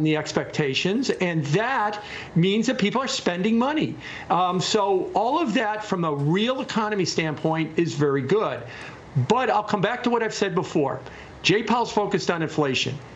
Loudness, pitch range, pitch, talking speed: -23 LUFS, 160-215 Hz, 195 Hz, 170 wpm